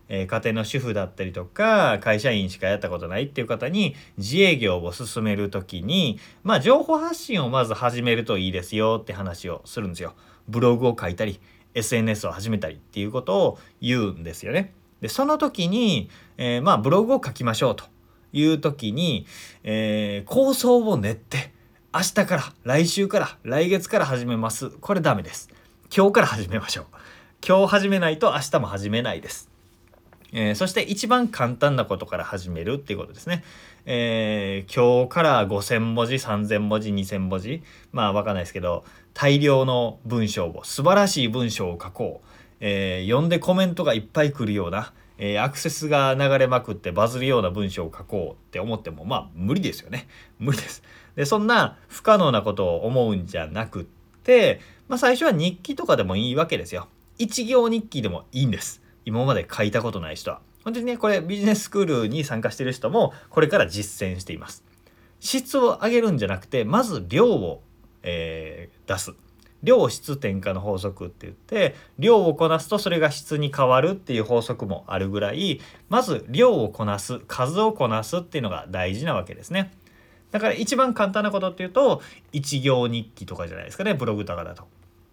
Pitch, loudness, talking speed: 120 Hz, -23 LUFS, 350 characters per minute